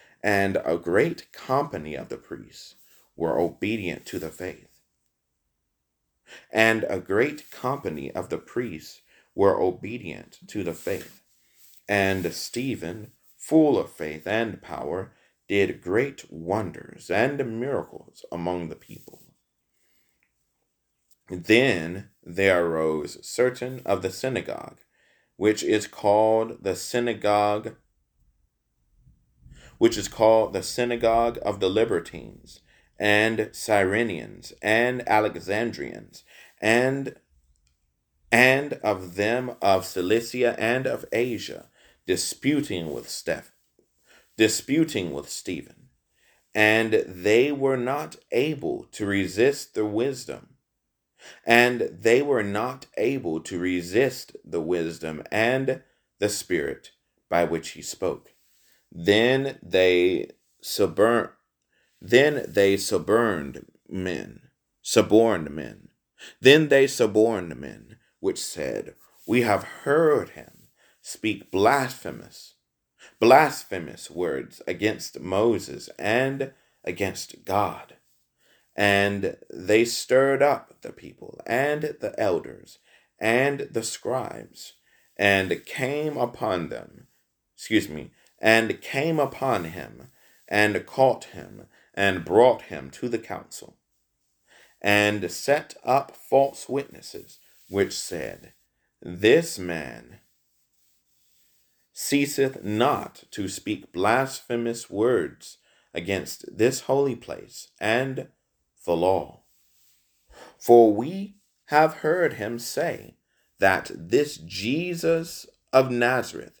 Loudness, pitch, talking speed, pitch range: -24 LUFS, 110 Hz, 100 wpm, 90-125 Hz